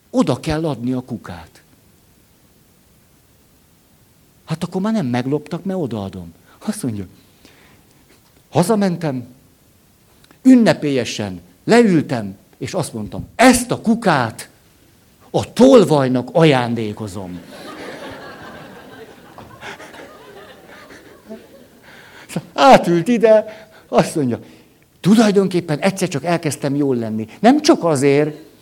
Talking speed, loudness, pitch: 85 wpm, -16 LUFS, 145 Hz